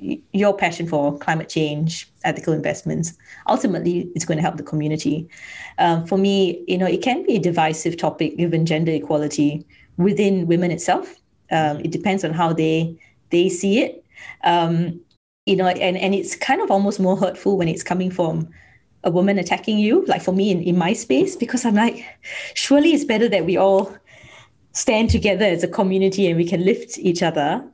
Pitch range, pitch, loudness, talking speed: 165-195 Hz, 180 Hz, -20 LUFS, 185 wpm